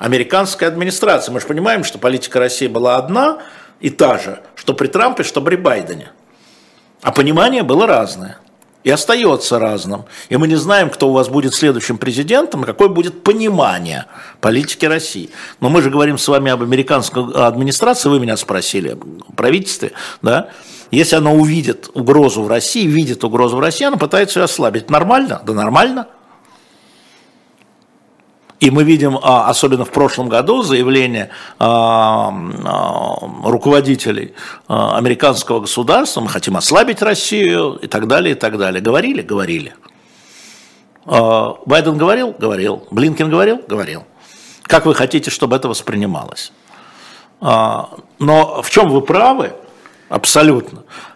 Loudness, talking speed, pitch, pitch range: -13 LUFS, 135 wpm, 145 Hz, 125-180 Hz